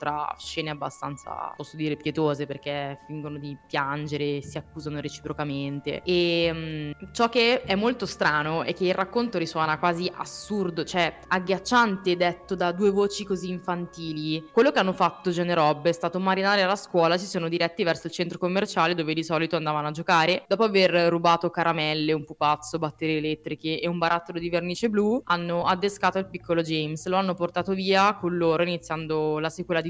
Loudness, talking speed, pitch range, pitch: -25 LUFS, 175 wpm, 155-185 Hz, 170 Hz